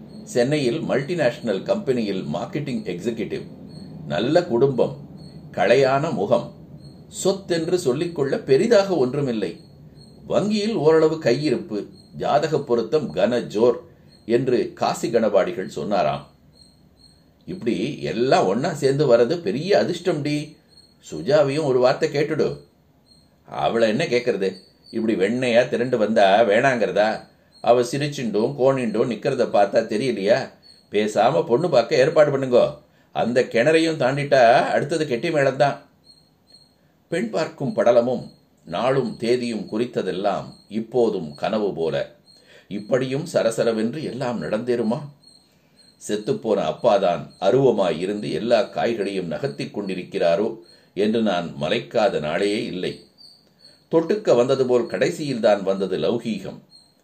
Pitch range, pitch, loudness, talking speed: 120-160 Hz, 135 Hz, -21 LUFS, 95 wpm